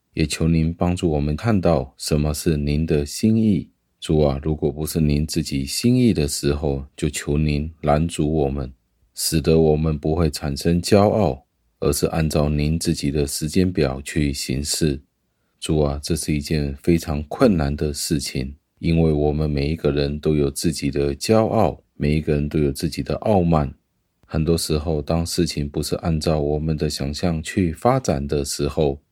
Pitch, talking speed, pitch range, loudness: 75 Hz, 250 characters per minute, 70-85 Hz, -21 LUFS